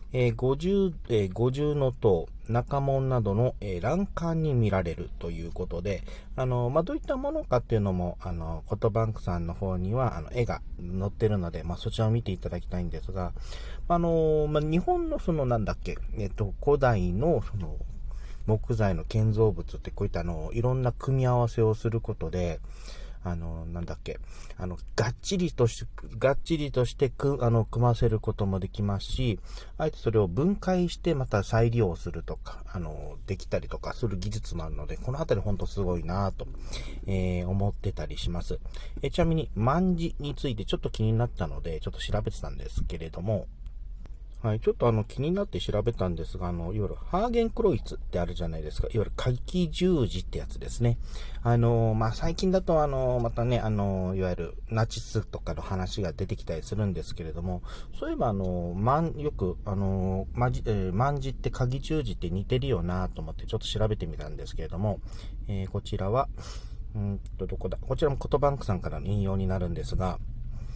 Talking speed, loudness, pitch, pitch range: 395 characters per minute, -29 LUFS, 105 Hz, 90-125 Hz